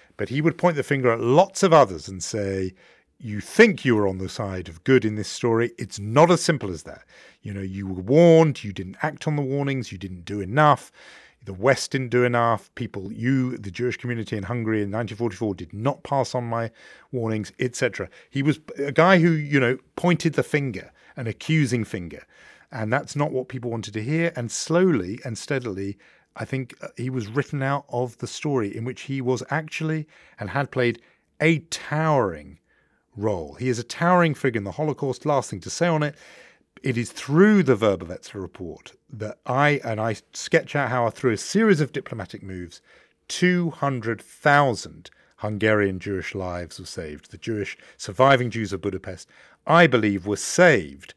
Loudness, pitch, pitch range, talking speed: -23 LUFS, 125 Hz, 105-145 Hz, 190 wpm